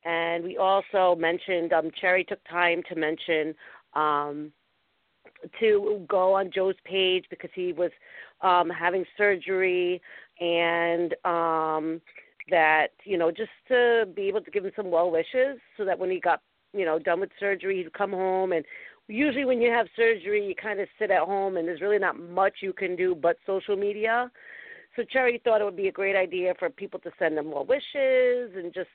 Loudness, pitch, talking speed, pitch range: -26 LUFS, 185 Hz, 190 wpm, 170-215 Hz